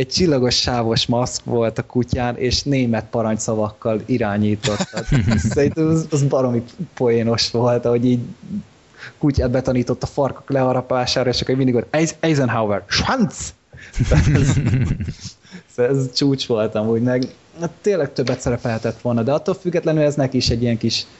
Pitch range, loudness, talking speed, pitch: 115-140 Hz, -19 LUFS, 140 wpm, 125 Hz